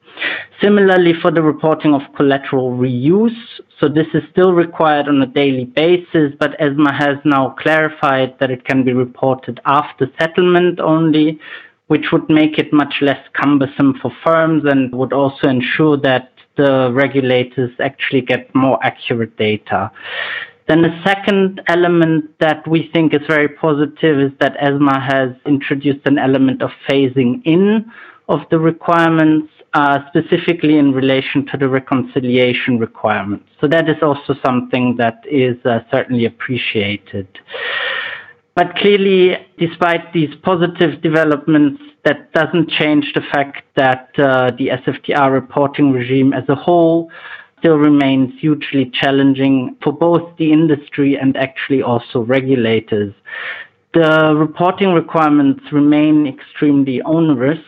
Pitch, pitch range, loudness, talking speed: 145 Hz, 135-160 Hz, -14 LUFS, 135 wpm